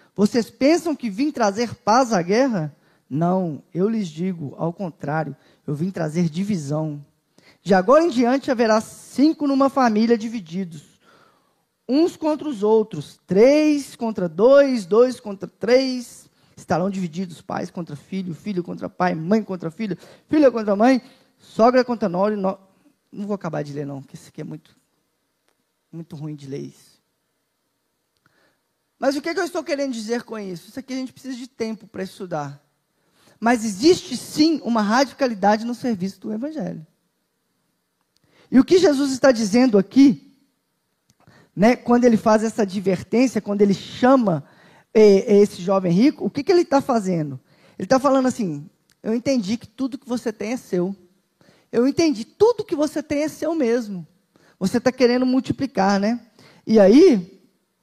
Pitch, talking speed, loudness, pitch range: 220 Hz, 160 wpm, -20 LUFS, 180-260 Hz